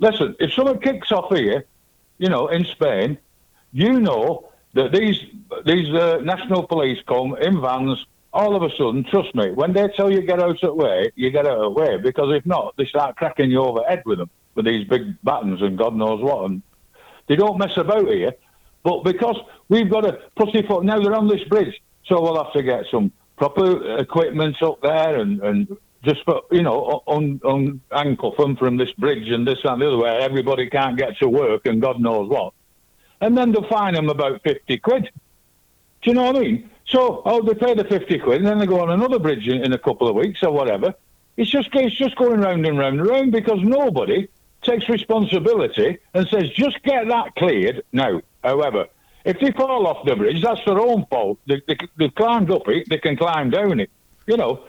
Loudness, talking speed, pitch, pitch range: -19 LUFS, 215 wpm, 185 Hz, 145-225 Hz